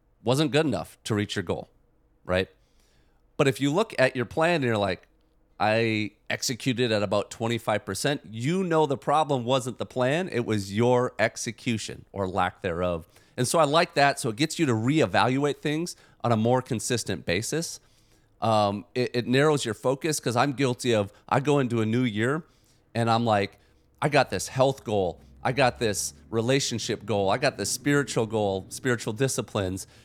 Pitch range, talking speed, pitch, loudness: 105-135 Hz, 180 wpm, 120 Hz, -26 LUFS